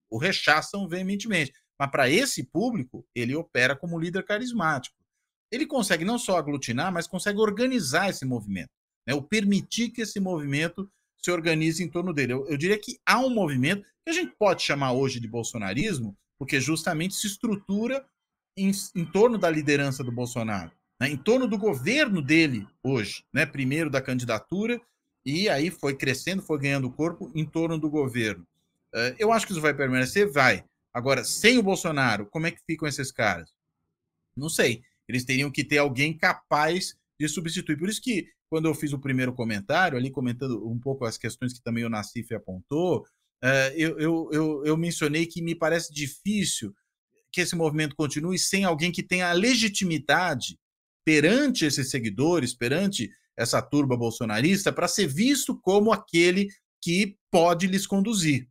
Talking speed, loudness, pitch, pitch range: 170 wpm, -26 LUFS, 160 Hz, 135-195 Hz